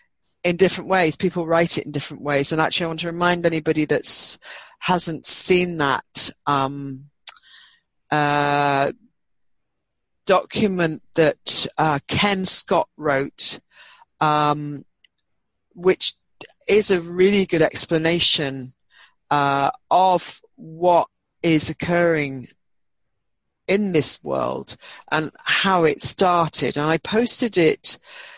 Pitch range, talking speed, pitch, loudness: 145-180 Hz, 110 wpm, 160 Hz, -19 LUFS